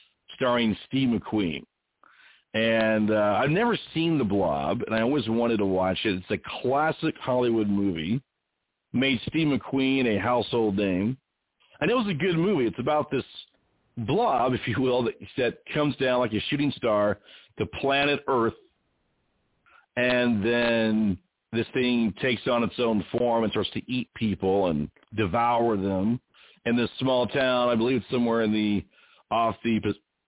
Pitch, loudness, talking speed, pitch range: 115 Hz, -26 LUFS, 160 wpm, 105-130 Hz